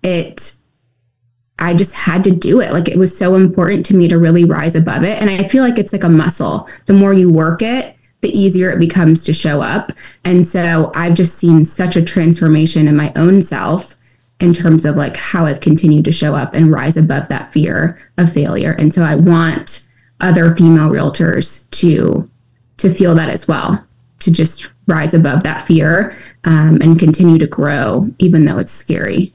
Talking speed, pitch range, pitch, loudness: 195 wpm, 155-180 Hz, 165 Hz, -12 LUFS